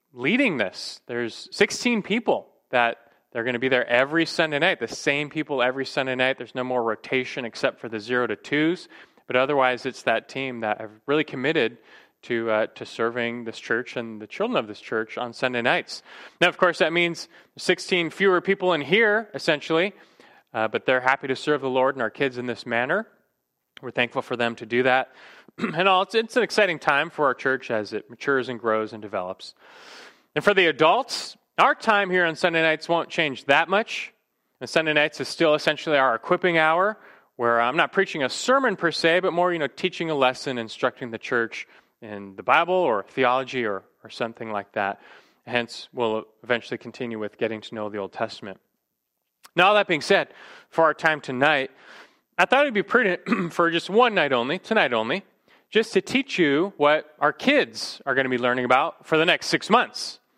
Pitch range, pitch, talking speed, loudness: 120-175 Hz, 135 Hz, 205 wpm, -23 LUFS